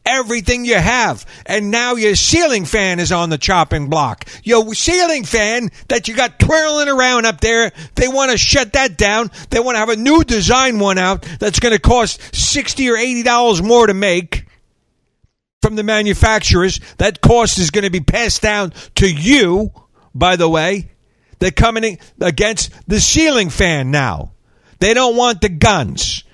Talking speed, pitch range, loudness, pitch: 180 wpm, 180-245 Hz, -13 LUFS, 215 Hz